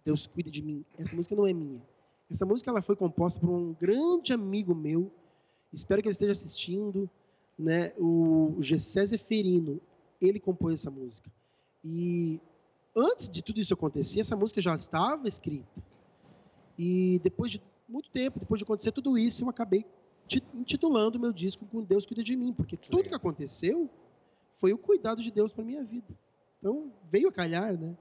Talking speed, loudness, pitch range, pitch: 175 wpm, -30 LUFS, 170-225 Hz, 195 Hz